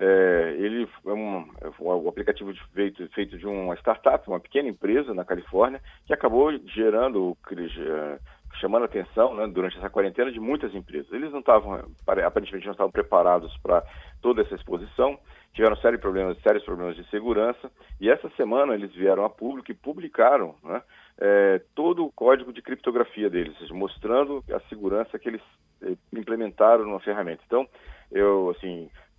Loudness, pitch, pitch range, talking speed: -25 LUFS, 100 Hz, 90-110 Hz, 170 wpm